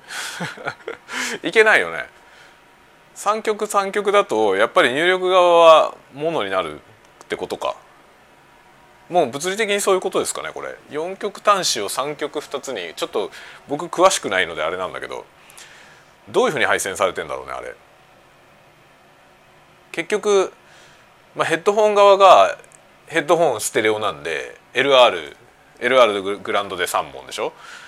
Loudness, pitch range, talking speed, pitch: -18 LUFS, 175-215 Hz, 280 characters per minute, 200 Hz